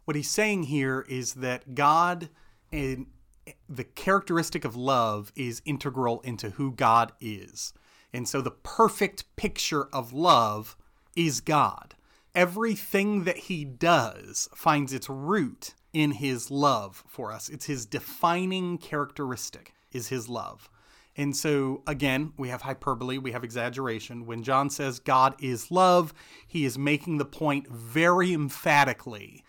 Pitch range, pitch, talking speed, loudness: 125-165 Hz, 140 Hz, 140 wpm, -27 LUFS